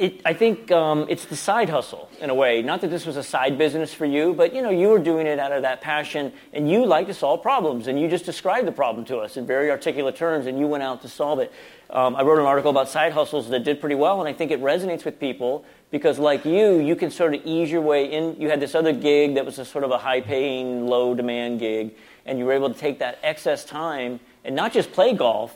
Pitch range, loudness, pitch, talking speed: 130-160 Hz, -22 LUFS, 145 Hz, 270 wpm